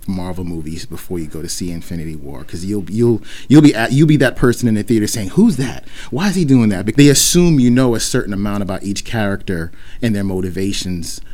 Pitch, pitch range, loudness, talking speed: 100 Hz, 90-125 Hz, -15 LUFS, 240 wpm